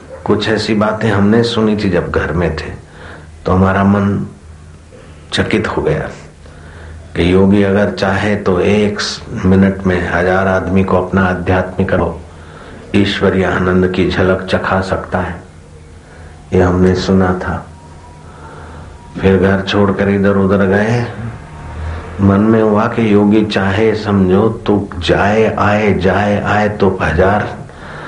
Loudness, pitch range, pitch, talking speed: -13 LUFS, 85-100 Hz, 95 Hz, 130 wpm